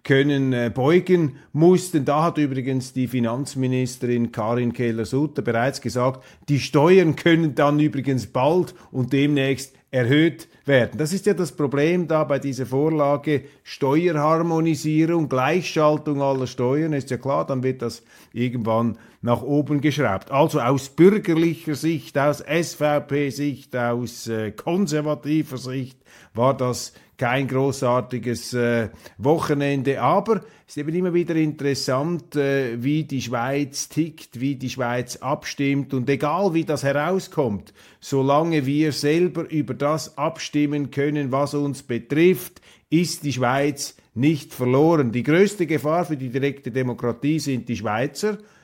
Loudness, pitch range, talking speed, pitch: -22 LUFS, 130-155 Hz, 130 wpm, 140 Hz